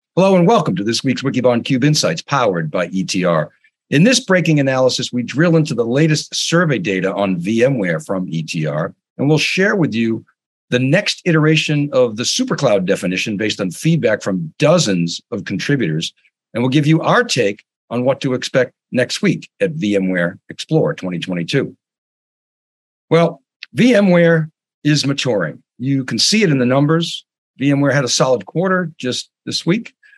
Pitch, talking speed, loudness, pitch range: 140 Hz, 160 wpm, -16 LUFS, 115-165 Hz